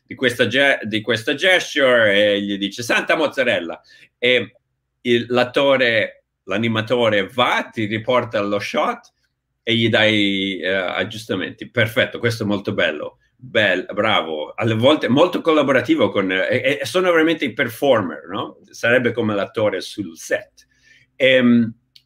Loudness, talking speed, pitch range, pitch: -18 LUFS, 135 wpm, 105-130 Hz, 115 Hz